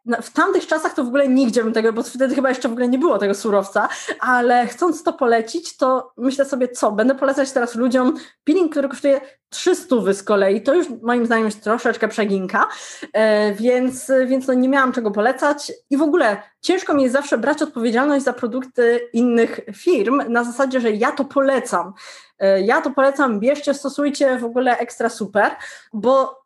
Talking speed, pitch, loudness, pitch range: 180 wpm, 255 Hz, -18 LUFS, 230-275 Hz